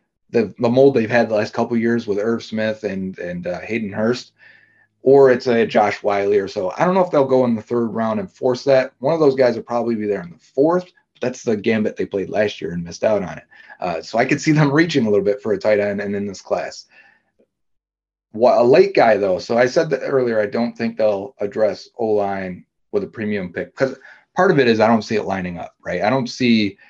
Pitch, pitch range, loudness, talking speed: 115 Hz, 100-130 Hz, -18 LUFS, 260 wpm